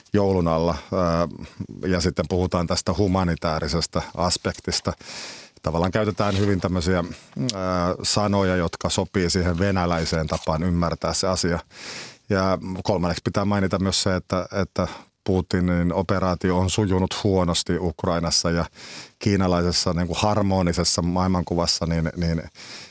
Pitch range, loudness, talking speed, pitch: 85-95 Hz, -23 LUFS, 115 wpm, 90 Hz